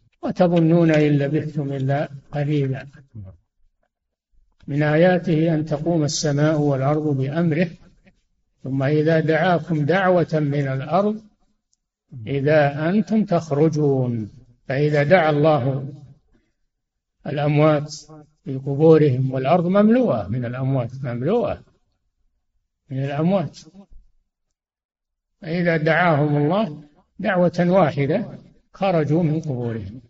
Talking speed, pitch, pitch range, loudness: 85 wpm, 150 Hz, 135-170 Hz, -20 LUFS